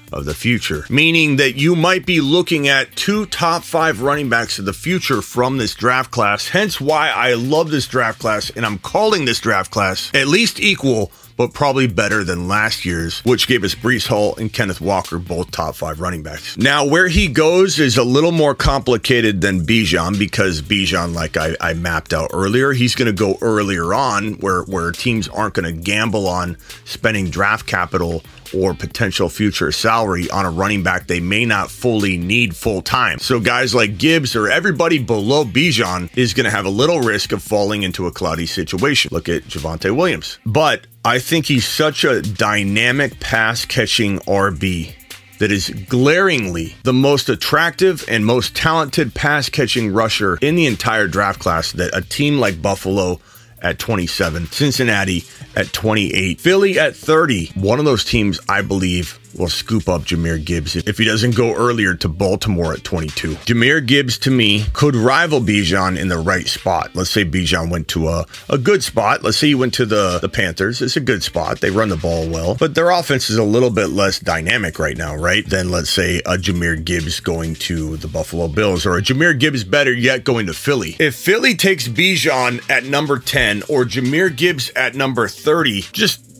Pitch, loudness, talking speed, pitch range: 110 Hz, -16 LUFS, 190 wpm, 95-130 Hz